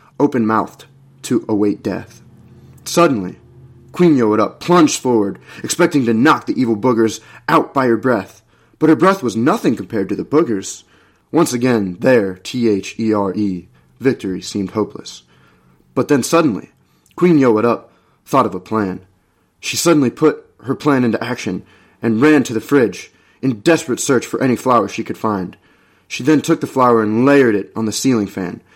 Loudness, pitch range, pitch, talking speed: -16 LUFS, 100-135 Hz, 115 Hz, 175 wpm